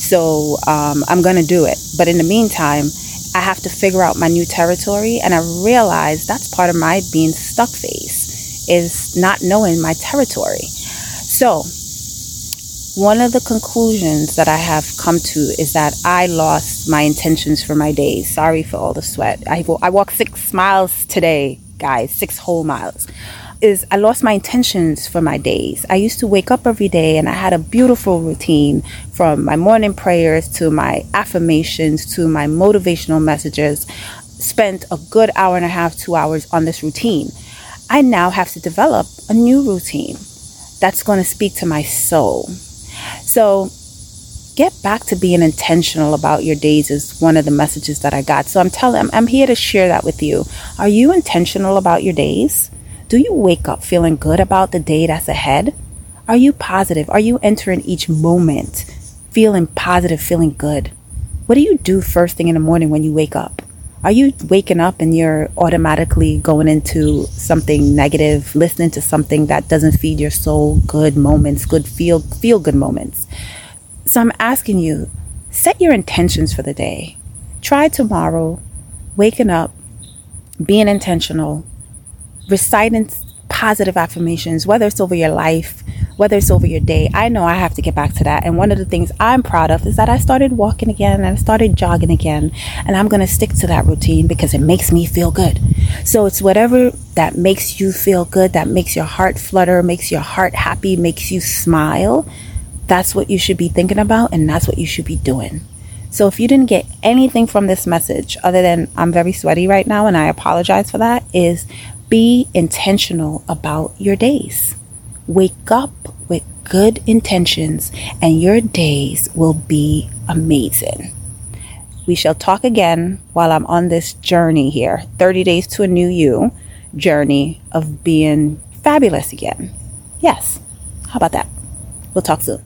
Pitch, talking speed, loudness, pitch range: 170 Hz, 180 wpm, -14 LUFS, 150-195 Hz